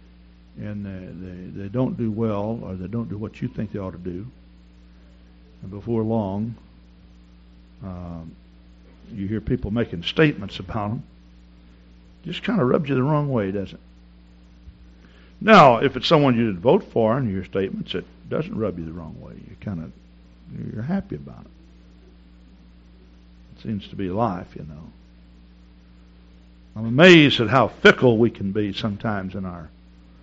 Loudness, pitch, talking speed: -21 LUFS, 90 Hz, 165 wpm